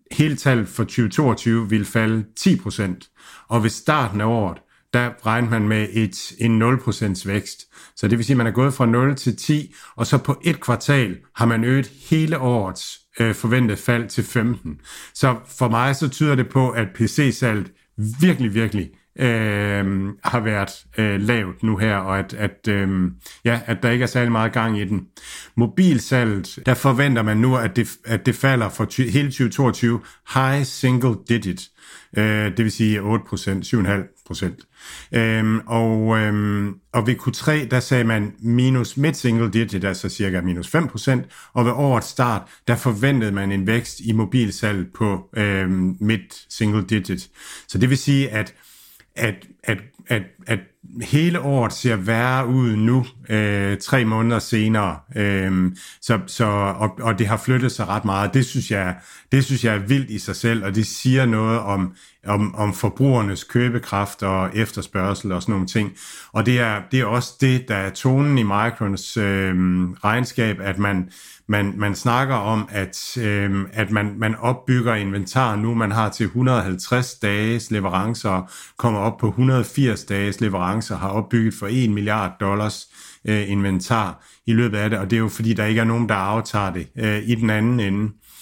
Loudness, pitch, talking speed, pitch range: -20 LUFS, 110 Hz, 175 wpm, 100-125 Hz